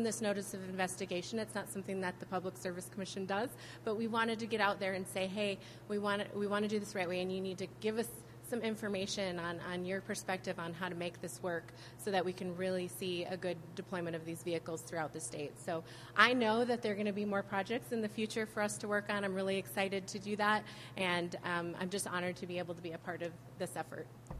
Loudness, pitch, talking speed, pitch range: -38 LUFS, 190 Hz, 260 wpm, 175-205 Hz